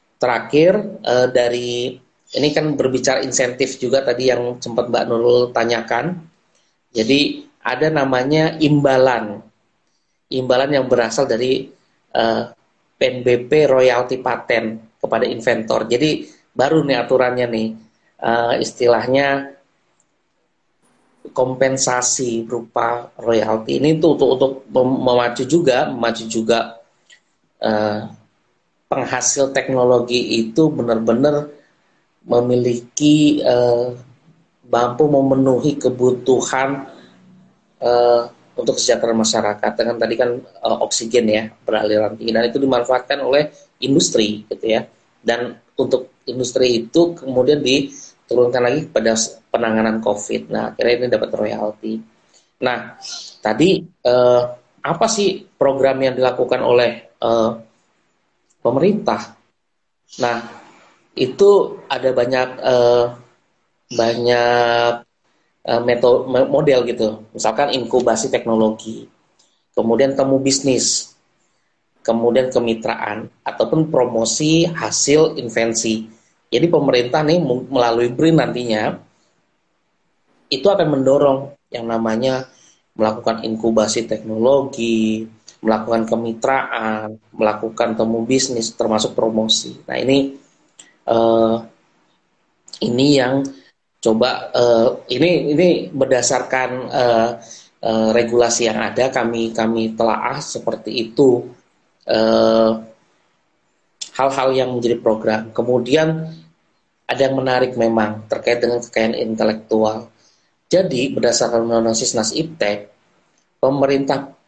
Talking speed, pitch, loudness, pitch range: 95 wpm, 120 Hz, -17 LUFS, 115-135 Hz